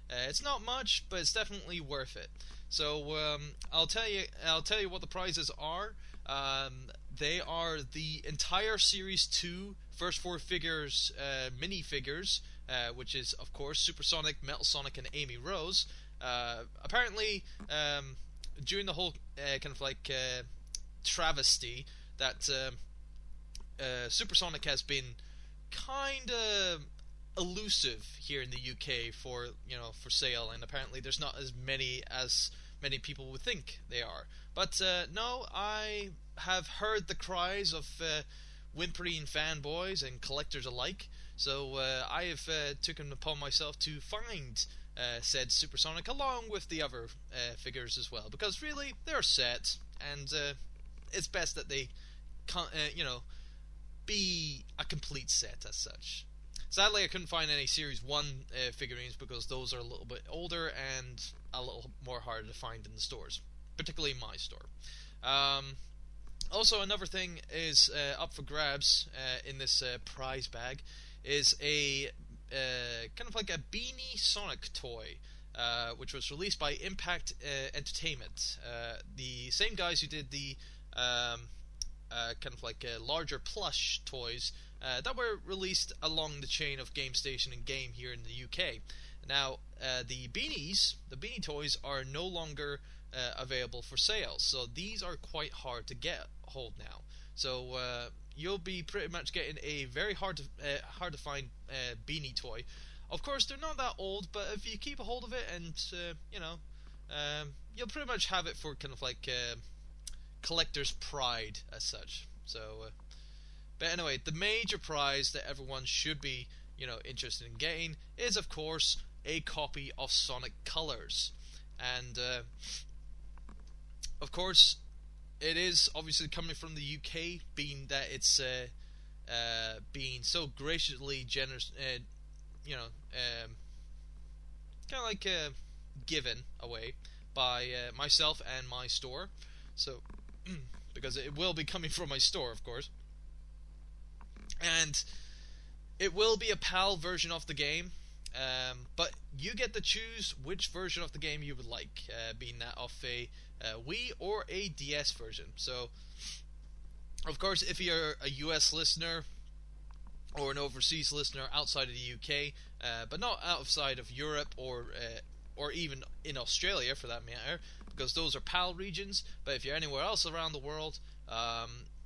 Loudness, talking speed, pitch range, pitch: -35 LUFS, 160 wpm, 125-165 Hz, 140 Hz